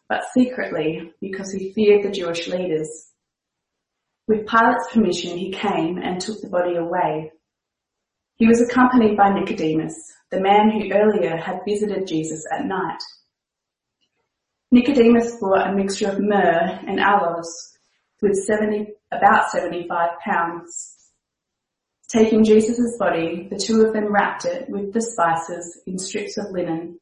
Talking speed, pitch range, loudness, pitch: 135 wpm, 170-215 Hz, -20 LUFS, 195 Hz